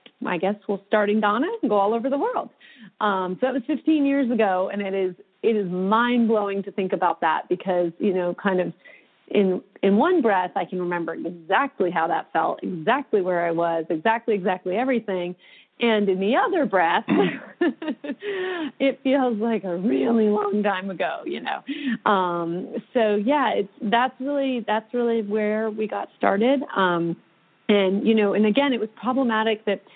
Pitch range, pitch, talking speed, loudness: 190-250 Hz, 215 Hz, 180 wpm, -23 LUFS